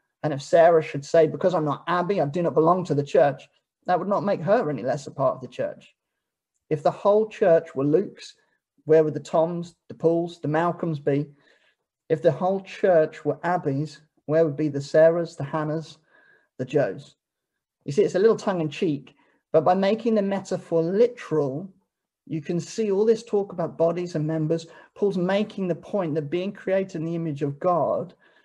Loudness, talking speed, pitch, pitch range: -24 LUFS, 200 wpm, 170 Hz, 155-195 Hz